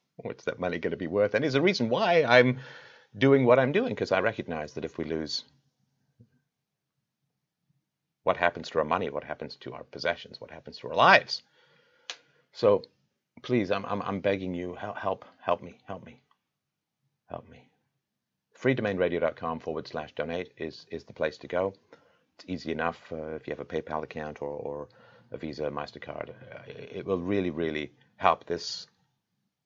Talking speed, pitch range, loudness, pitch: 175 wpm, 80-125 Hz, -28 LUFS, 95 Hz